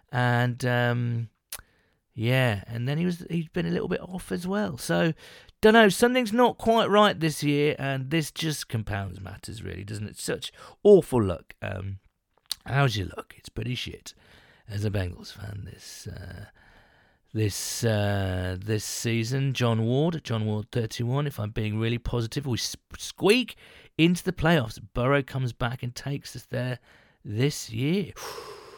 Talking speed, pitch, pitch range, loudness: 160 wpm, 125 Hz, 110-155 Hz, -26 LUFS